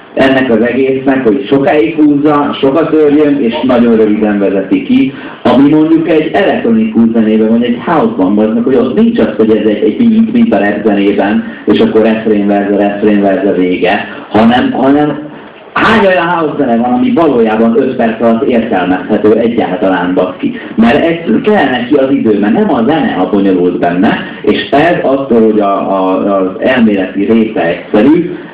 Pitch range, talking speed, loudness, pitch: 100-150 Hz, 160 wpm, -9 LUFS, 115 Hz